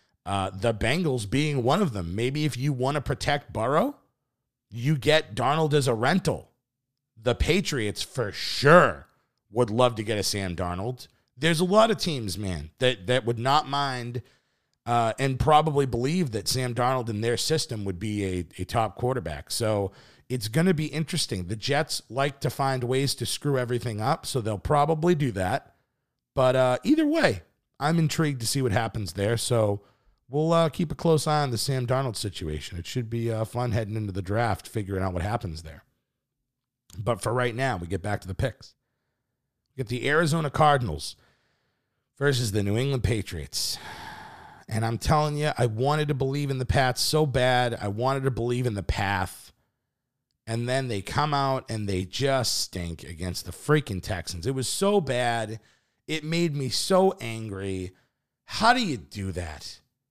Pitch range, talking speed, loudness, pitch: 110-145 Hz, 185 wpm, -26 LUFS, 125 Hz